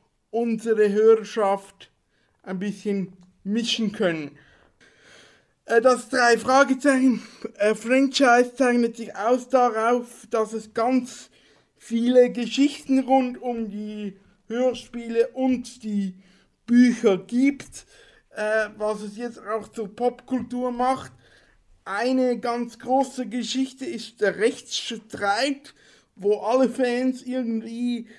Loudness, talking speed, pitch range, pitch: -23 LUFS, 100 wpm, 215-250 Hz, 235 Hz